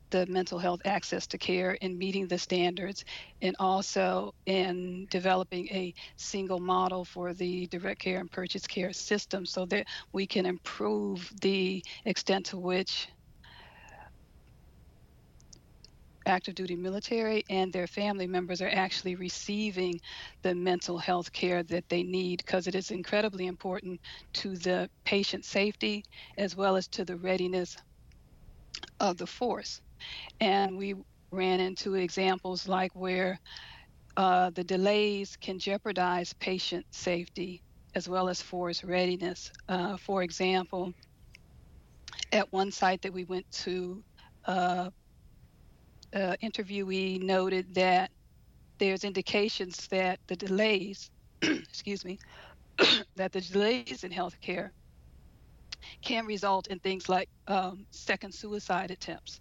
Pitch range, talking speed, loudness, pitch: 180-195 Hz, 125 wpm, -32 LUFS, 185 Hz